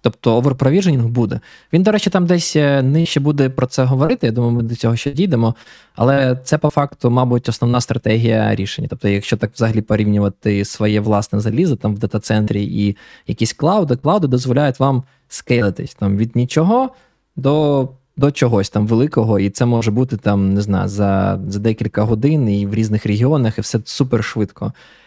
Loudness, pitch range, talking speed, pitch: -16 LUFS, 105-140 Hz, 170 wpm, 120 Hz